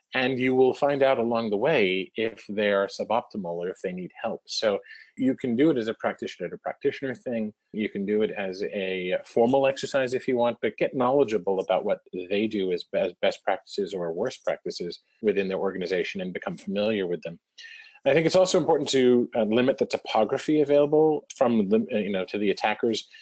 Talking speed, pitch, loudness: 195 wpm, 130 Hz, -26 LUFS